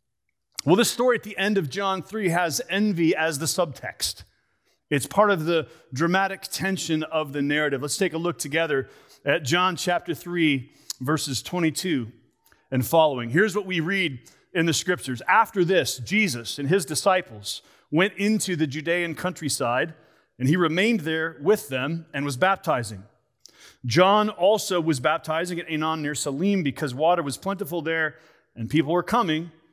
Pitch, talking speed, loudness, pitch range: 165 Hz, 160 wpm, -24 LUFS, 145-185 Hz